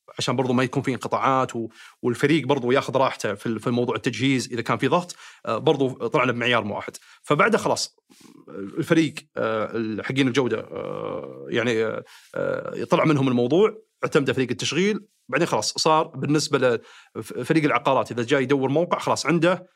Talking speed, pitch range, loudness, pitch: 135 wpm, 125-165 Hz, -23 LUFS, 140 Hz